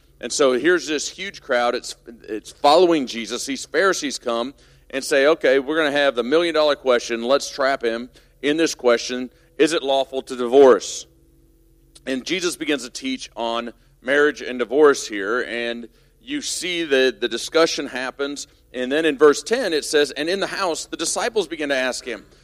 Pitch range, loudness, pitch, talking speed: 120-165 Hz, -20 LUFS, 140 Hz, 185 wpm